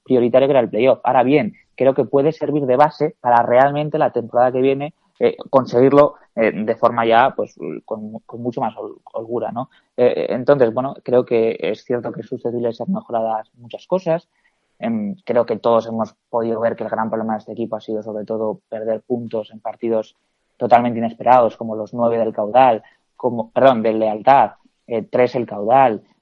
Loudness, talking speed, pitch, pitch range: -18 LUFS, 190 wpm, 120 Hz, 110-140 Hz